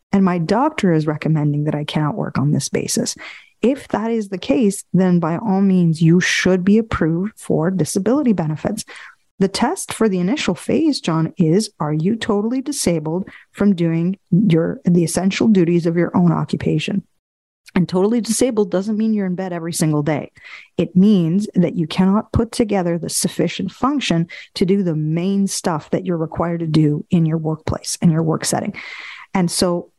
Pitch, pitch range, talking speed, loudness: 185 Hz, 165-205 Hz, 180 wpm, -18 LUFS